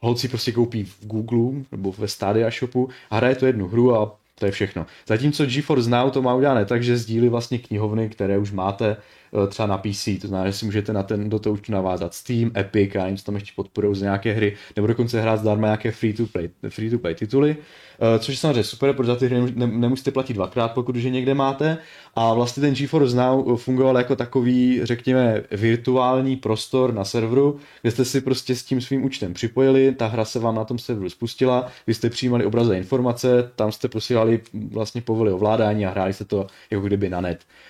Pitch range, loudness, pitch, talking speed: 105-125 Hz, -22 LUFS, 115 Hz, 205 wpm